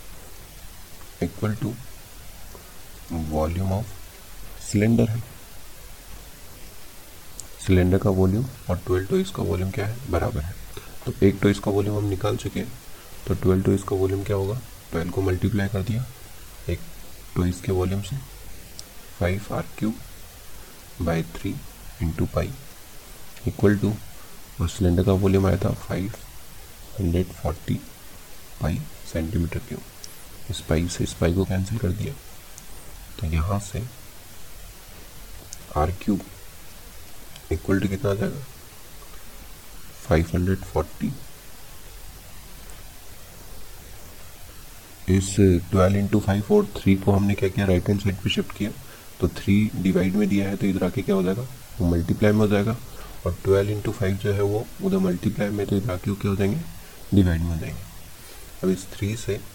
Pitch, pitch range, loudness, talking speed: 95 Hz, 85-105 Hz, -24 LUFS, 130 wpm